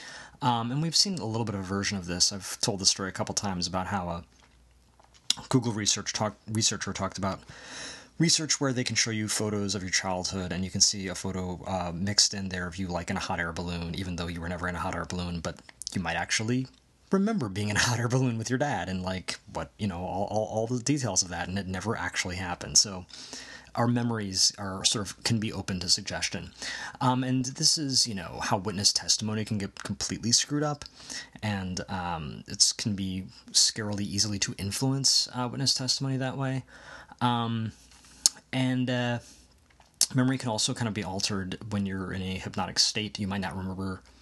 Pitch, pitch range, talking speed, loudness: 100 Hz, 95-120 Hz, 210 wpm, -28 LUFS